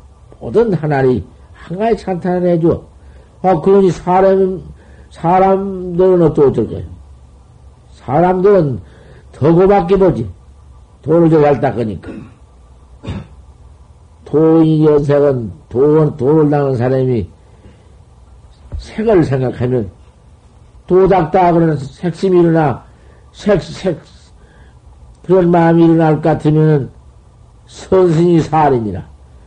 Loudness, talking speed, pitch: -12 LUFS, 200 characters per minute, 145 Hz